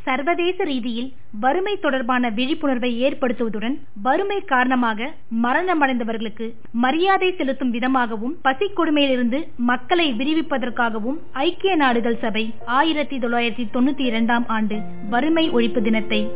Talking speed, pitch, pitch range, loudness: 100 wpm, 255 Hz, 235-290 Hz, -21 LUFS